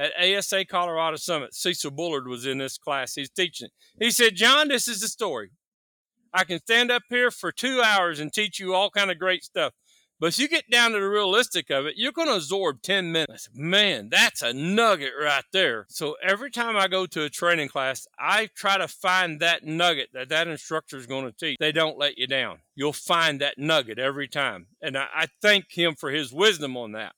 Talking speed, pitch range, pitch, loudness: 220 wpm, 145-205 Hz, 175 Hz, -23 LUFS